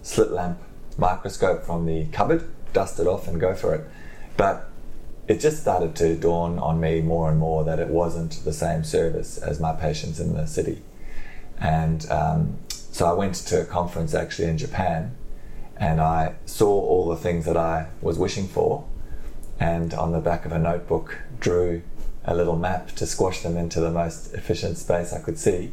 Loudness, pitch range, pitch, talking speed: -24 LUFS, 80-85 Hz, 85 Hz, 185 wpm